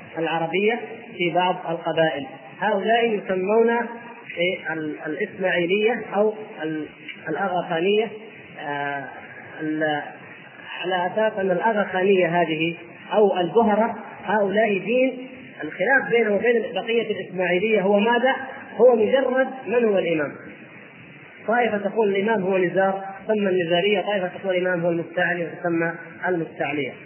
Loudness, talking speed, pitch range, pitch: -22 LUFS, 100 wpm, 175-220 Hz, 195 Hz